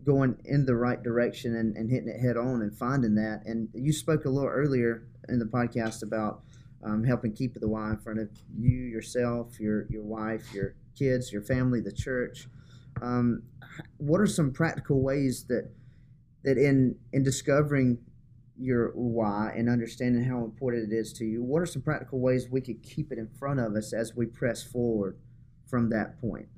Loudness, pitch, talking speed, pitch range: -29 LUFS, 120 Hz, 190 wpm, 115-130 Hz